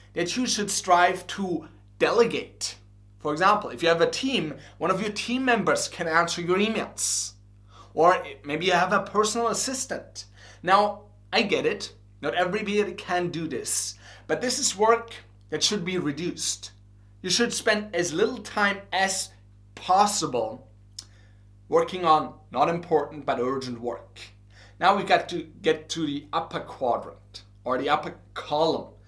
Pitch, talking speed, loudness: 155 Hz, 155 wpm, -25 LUFS